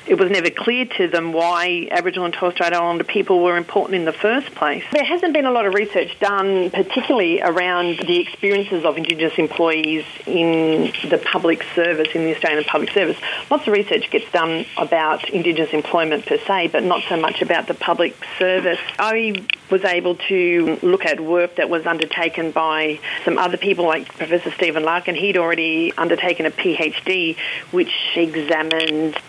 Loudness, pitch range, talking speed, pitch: -18 LUFS, 165-200 Hz, 175 wpm, 175 Hz